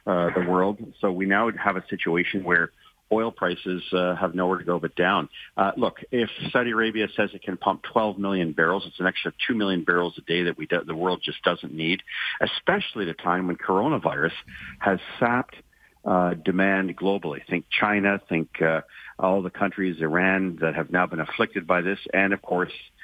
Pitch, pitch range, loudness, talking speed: 95 Hz, 85-100 Hz, -25 LUFS, 200 wpm